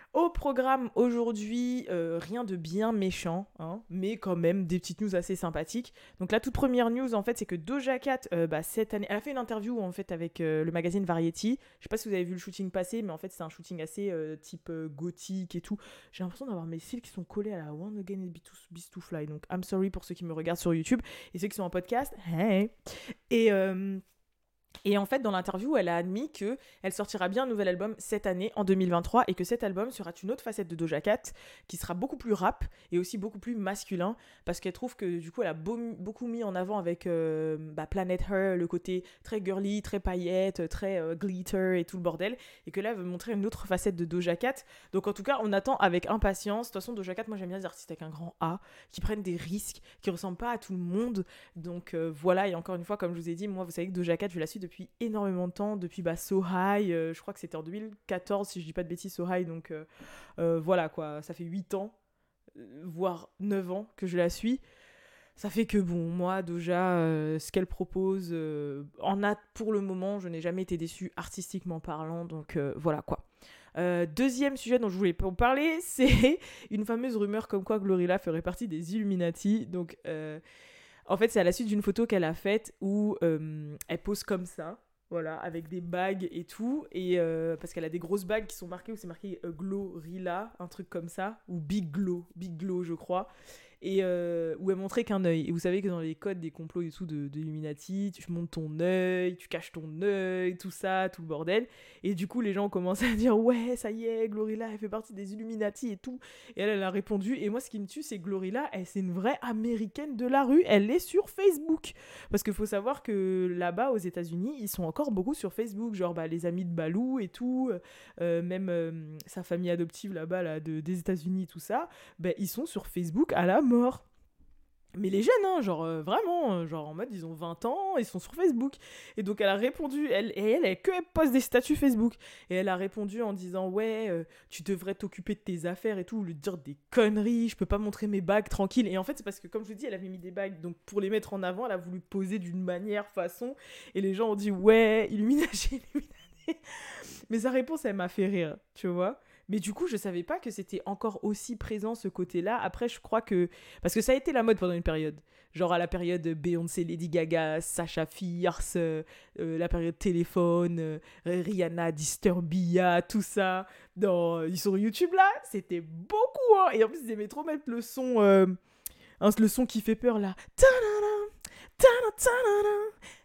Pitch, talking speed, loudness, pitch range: 190 Hz, 235 wpm, -31 LUFS, 175-220 Hz